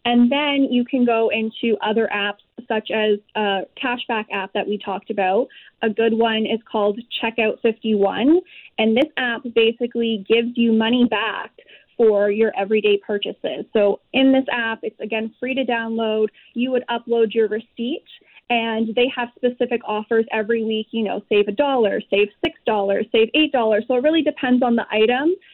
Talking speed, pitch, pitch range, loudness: 175 wpm, 225 Hz, 215-245 Hz, -20 LUFS